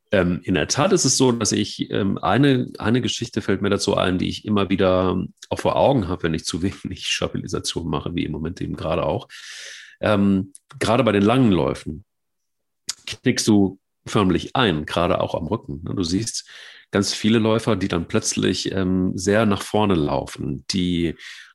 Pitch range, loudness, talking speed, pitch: 95-110 Hz, -21 LUFS, 170 wpm, 100 Hz